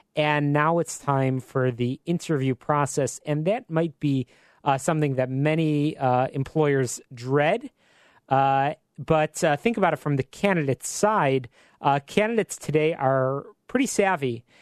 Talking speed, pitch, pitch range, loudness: 145 wpm, 145 Hz, 135-165 Hz, -24 LUFS